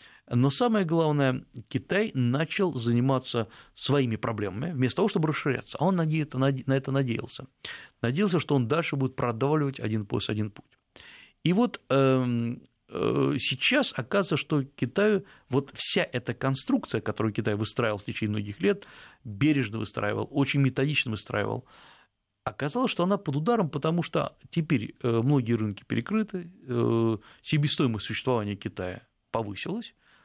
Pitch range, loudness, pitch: 115-155 Hz, -28 LUFS, 135 Hz